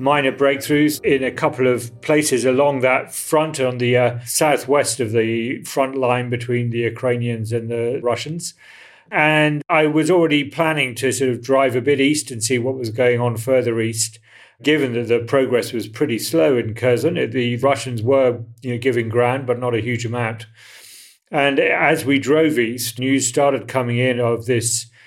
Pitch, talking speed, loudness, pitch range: 130 Hz, 180 wpm, -18 LUFS, 120-145 Hz